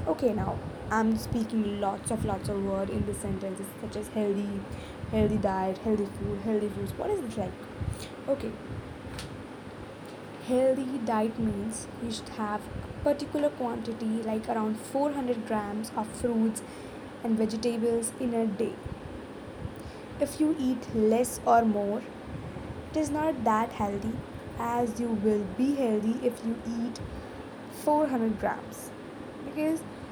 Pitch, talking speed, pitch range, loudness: 230 Hz, 135 wpm, 215-255 Hz, -30 LUFS